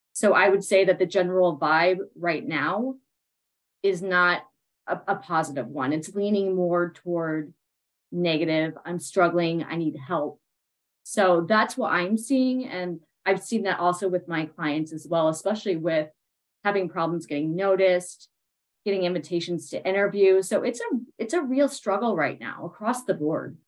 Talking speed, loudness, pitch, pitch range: 160 wpm, -25 LUFS, 180 Hz, 165-200 Hz